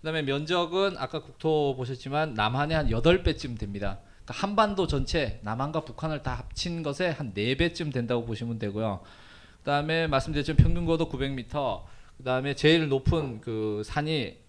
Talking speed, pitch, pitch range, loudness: 325 characters per minute, 140 Hz, 115-160 Hz, -28 LUFS